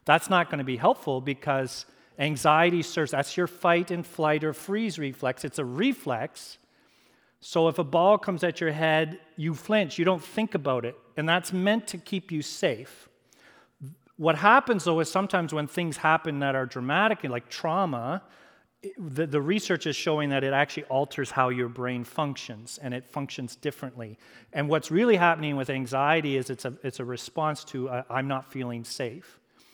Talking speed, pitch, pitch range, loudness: 180 wpm, 150 Hz, 135-175 Hz, -27 LUFS